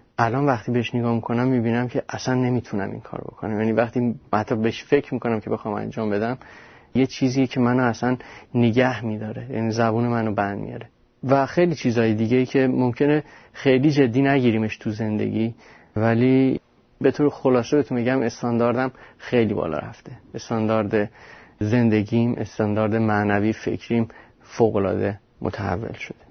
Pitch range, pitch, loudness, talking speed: 110-130 Hz, 120 Hz, -22 LUFS, 145 wpm